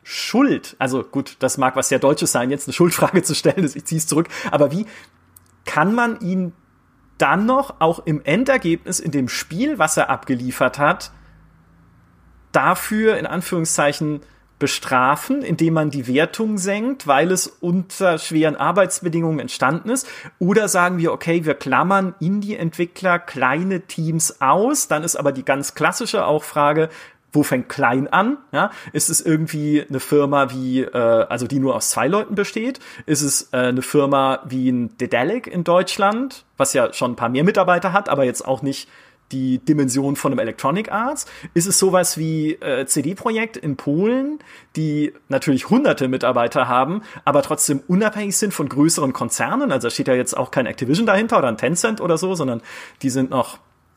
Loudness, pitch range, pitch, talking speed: -19 LUFS, 135-185 Hz, 155 Hz, 170 wpm